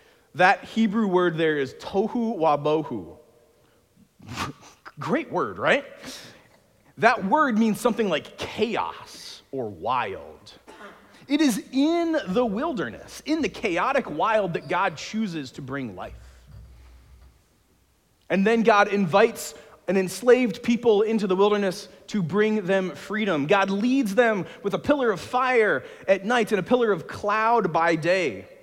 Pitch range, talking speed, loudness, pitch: 180-240 Hz, 135 wpm, -23 LUFS, 210 Hz